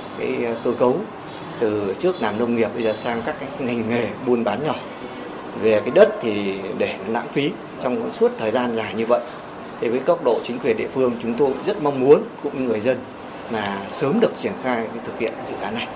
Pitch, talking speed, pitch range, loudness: 115 Hz, 220 wpm, 105-120 Hz, -22 LUFS